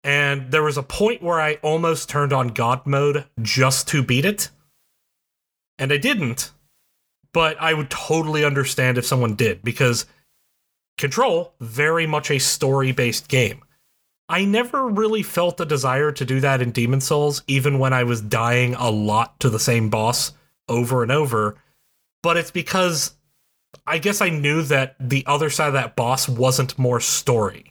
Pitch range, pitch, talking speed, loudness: 125-155 Hz, 140 Hz, 165 wpm, -20 LUFS